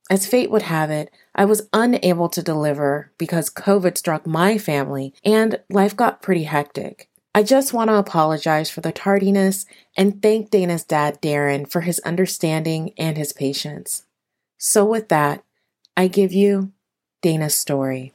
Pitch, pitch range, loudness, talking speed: 175 Hz, 150-200 Hz, -19 LUFS, 155 wpm